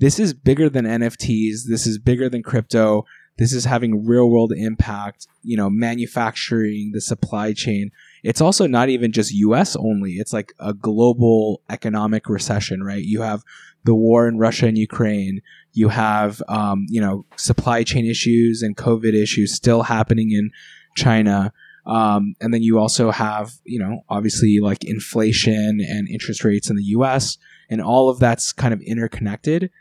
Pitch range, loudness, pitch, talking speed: 105-120 Hz, -19 LUFS, 110 Hz, 165 wpm